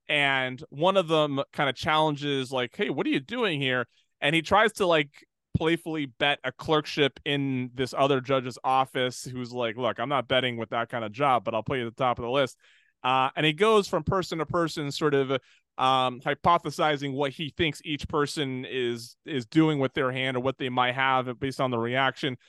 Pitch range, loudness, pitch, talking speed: 130-155 Hz, -26 LUFS, 140 Hz, 215 wpm